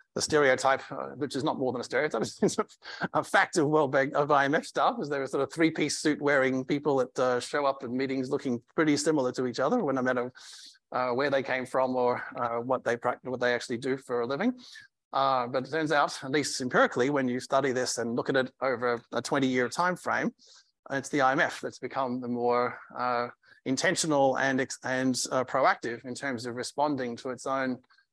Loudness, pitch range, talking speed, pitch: -28 LUFS, 125-140 Hz, 220 wpm, 130 Hz